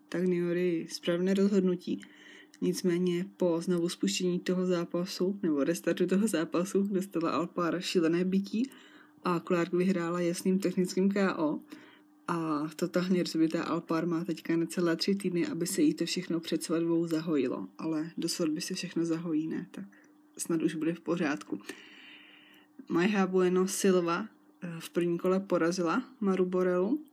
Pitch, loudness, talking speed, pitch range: 175 Hz, -31 LUFS, 140 wpm, 165-190 Hz